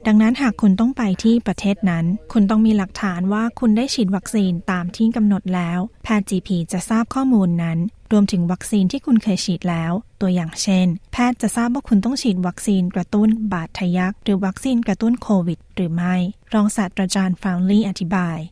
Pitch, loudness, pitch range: 200 Hz, -19 LUFS, 180-220 Hz